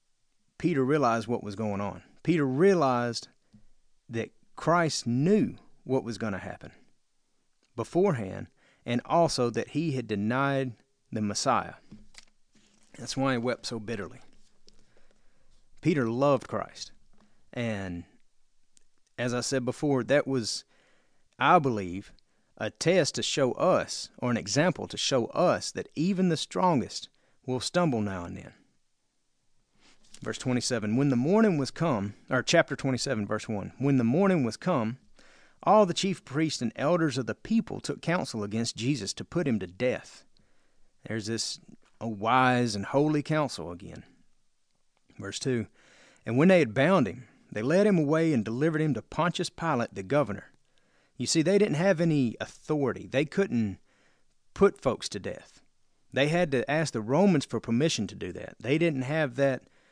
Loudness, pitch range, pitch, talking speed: -28 LUFS, 115-155 Hz, 130 Hz, 155 wpm